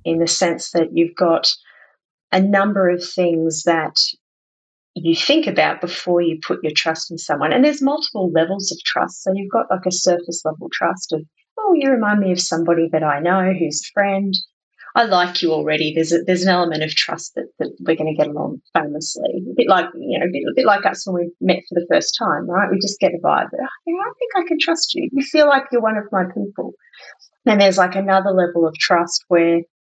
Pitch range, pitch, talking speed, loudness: 165-205 Hz, 180 Hz, 230 wpm, -18 LUFS